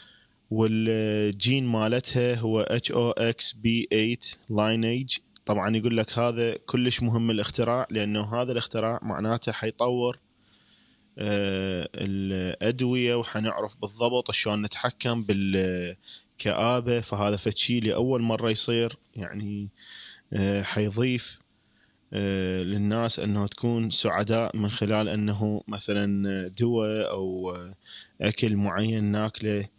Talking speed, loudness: 85 wpm, -26 LUFS